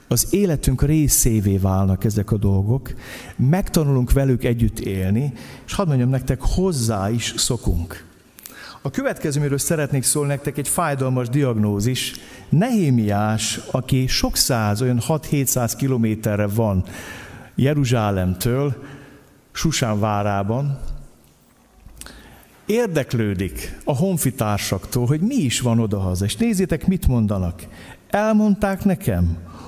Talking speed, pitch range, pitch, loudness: 100 wpm, 105-145 Hz, 125 Hz, -20 LUFS